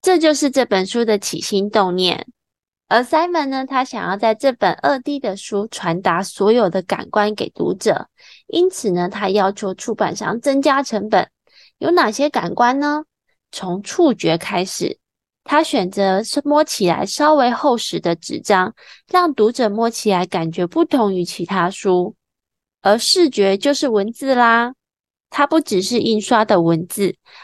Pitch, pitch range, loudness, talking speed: 220 Hz, 190-280 Hz, -17 LUFS, 235 characters per minute